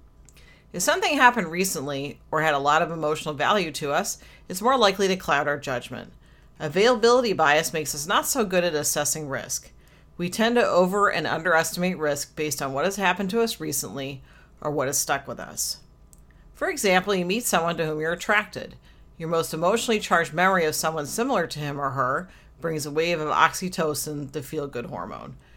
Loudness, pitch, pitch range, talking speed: -24 LUFS, 160 Hz, 150-190 Hz, 190 wpm